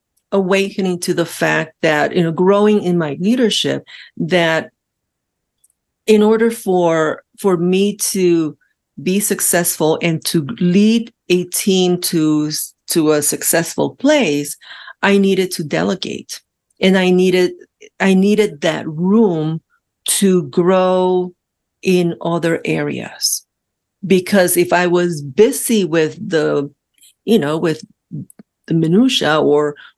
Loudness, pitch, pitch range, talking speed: -15 LUFS, 180 Hz, 165-200 Hz, 120 wpm